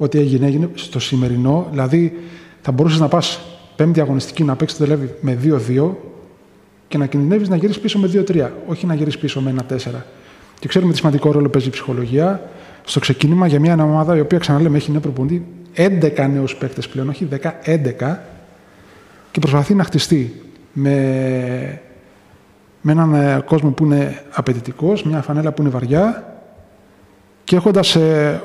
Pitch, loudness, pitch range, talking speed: 150 Hz, -16 LUFS, 135-170 Hz, 160 wpm